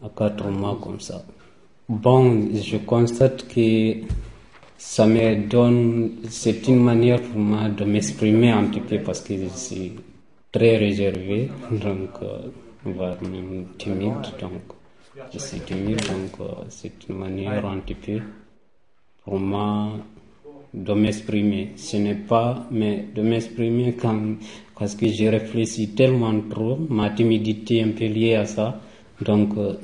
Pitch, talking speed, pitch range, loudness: 110 Hz, 145 wpm, 105-115 Hz, -22 LUFS